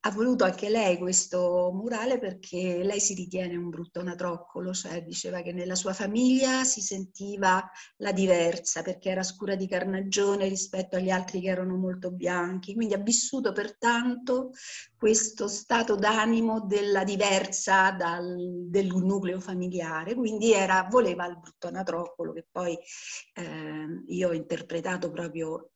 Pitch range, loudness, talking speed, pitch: 180-210 Hz, -28 LUFS, 140 wpm, 190 Hz